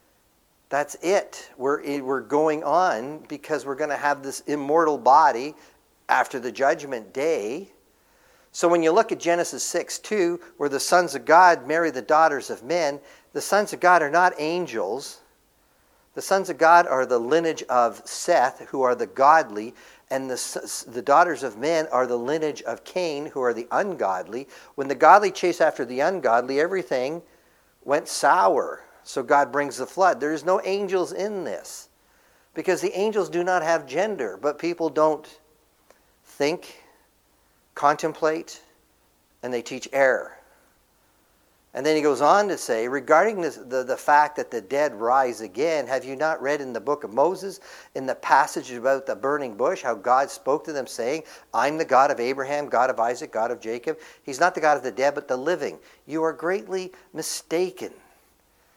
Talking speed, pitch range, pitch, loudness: 175 wpm, 140-180 Hz, 155 Hz, -23 LUFS